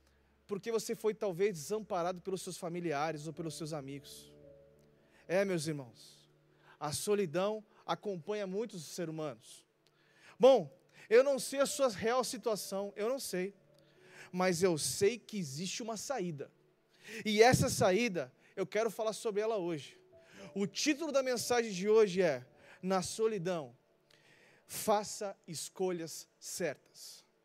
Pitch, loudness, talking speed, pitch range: 190 Hz, -34 LUFS, 130 wpm, 165-215 Hz